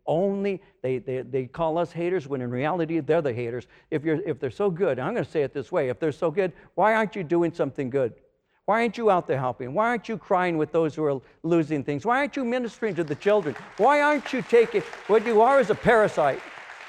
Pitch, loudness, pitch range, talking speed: 175 Hz, -25 LUFS, 150-220 Hz, 250 wpm